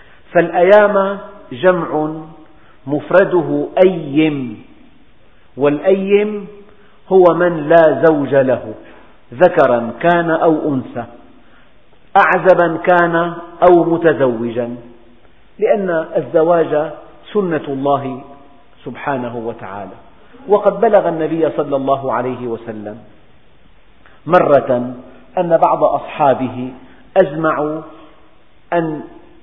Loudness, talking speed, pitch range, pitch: -14 LUFS, 75 wpm, 130-175 Hz, 155 Hz